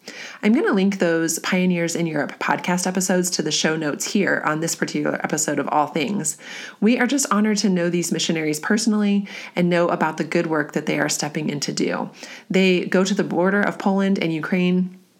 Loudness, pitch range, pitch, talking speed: -21 LUFS, 165-200 Hz, 180 Hz, 210 wpm